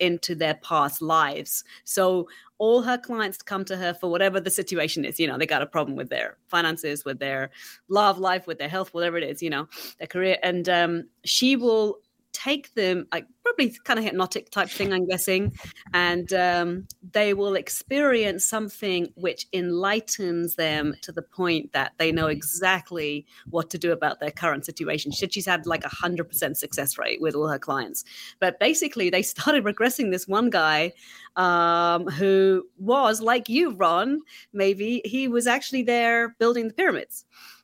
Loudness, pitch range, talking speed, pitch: -24 LUFS, 165-215 Hz, 175 wpm, 185 Hz